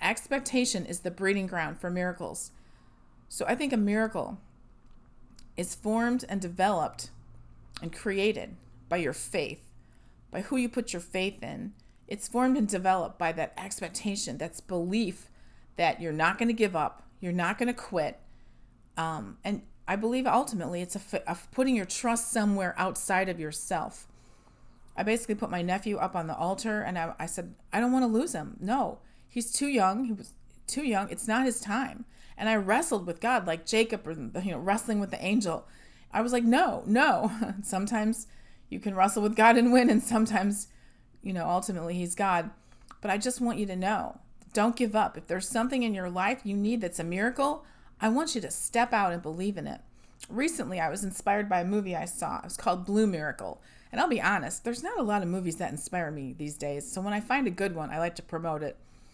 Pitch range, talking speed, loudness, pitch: 175-230 Hz, 205 wpm, -29 LUFS, 200 Hz